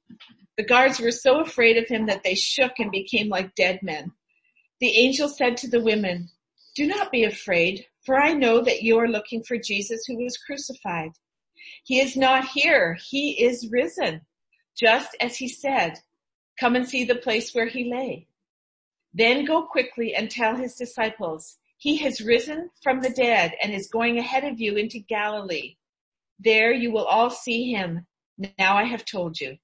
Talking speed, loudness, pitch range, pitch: 180 wpm, -23 LUFS, 210-260 Hz, 235 Hz